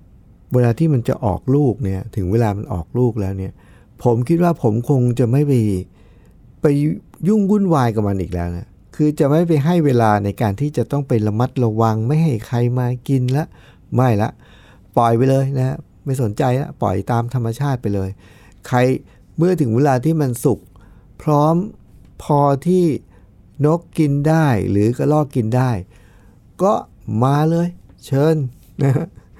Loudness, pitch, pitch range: -18 LUFS, 125 Hz, 105-145 Hz